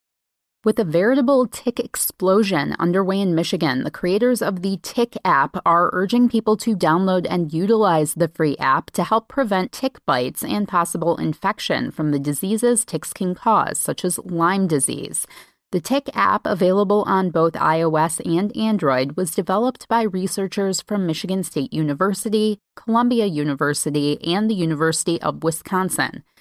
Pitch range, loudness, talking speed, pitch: 165-215 Hz, -20 LUFS, 150 wpm, 190 Hz